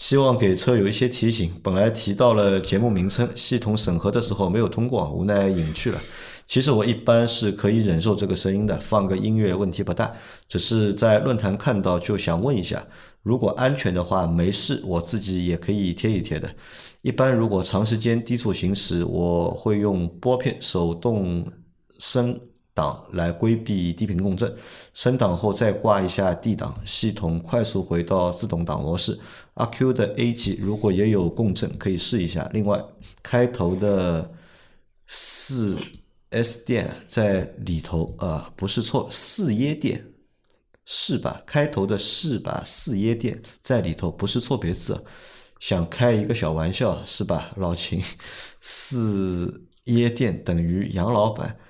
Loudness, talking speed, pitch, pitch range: -22 LUFS, 240 characters per minute, 105 Hz, 90-120 Hz